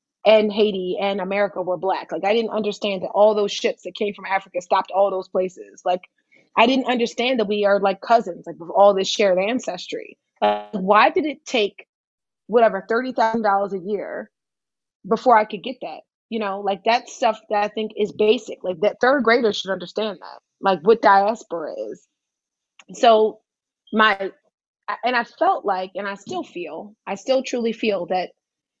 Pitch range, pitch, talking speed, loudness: 195-230 Hz, 210 Hz, 180 wpm, -20 LUFS